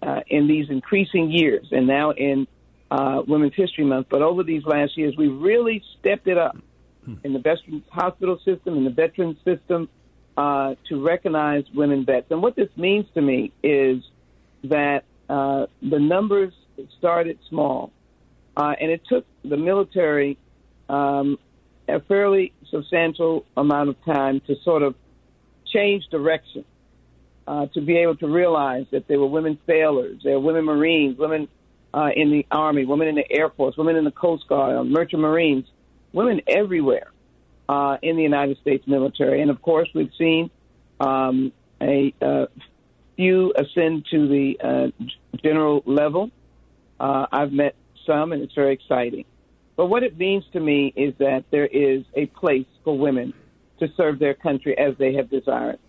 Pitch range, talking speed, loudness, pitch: 135-165 Hz, 165 wpm, -21 LUFS, 145 Hz